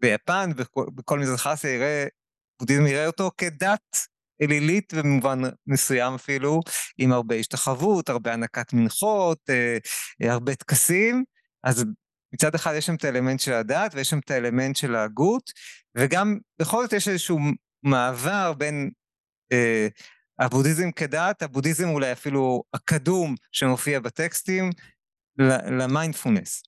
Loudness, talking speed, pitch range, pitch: -24 LUFS, 120 wpm, 130-175 Hz, 145 Hz